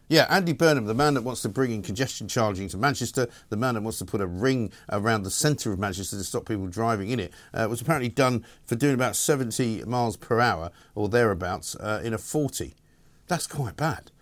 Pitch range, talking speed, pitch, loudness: 105-130 Hz, 225 wpm, 115 Hz, -26 LUFS